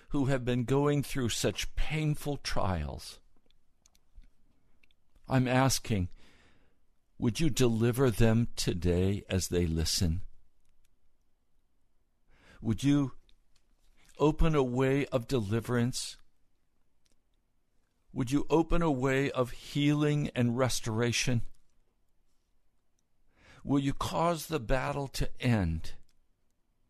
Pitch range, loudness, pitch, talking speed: 95-135 Hz, -30 LUFS, 120 Hz, 90 wpm